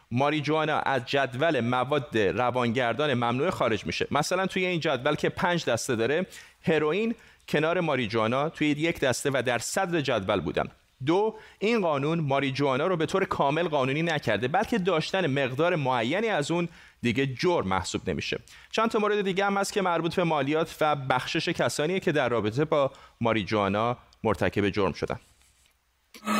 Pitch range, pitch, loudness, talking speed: 125-170 Hz, 150 Hz, -27 LUFS, 155 wpm